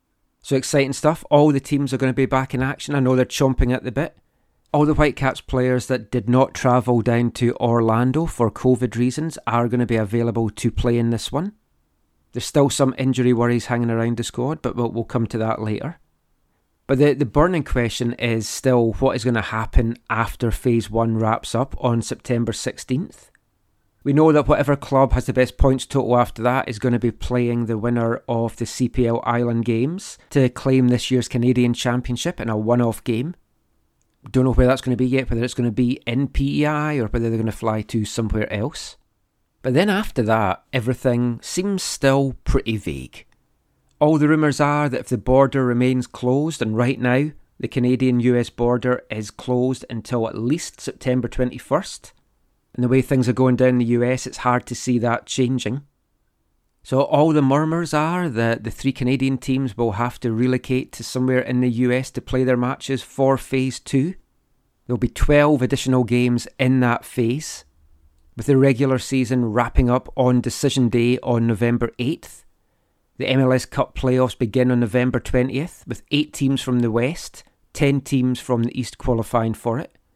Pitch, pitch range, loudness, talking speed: 125 Hz, 115-135 Hz, -20 LUFS, 190 wpm